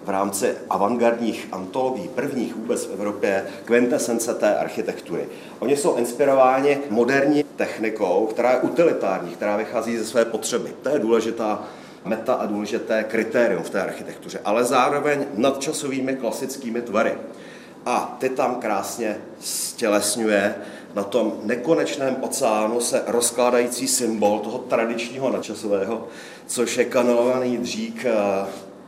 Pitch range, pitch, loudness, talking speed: 110-130 Hz, 120 Hz, -22 LUFS, 120 wpm